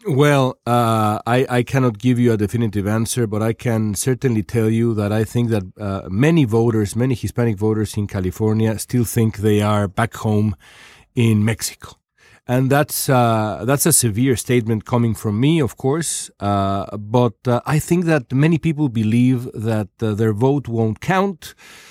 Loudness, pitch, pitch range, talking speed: -18 LUFS, 115 Hz, 110-130 Hz, 175 wpm